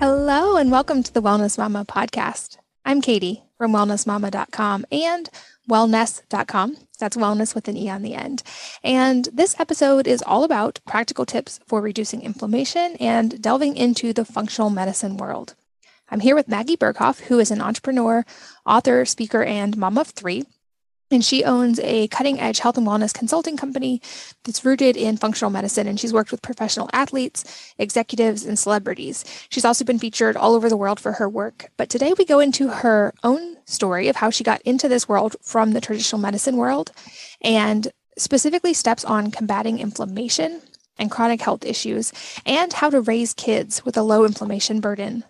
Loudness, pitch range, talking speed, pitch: -20 LUFS, 215-265 Hz, 175 wpm, 230 Hz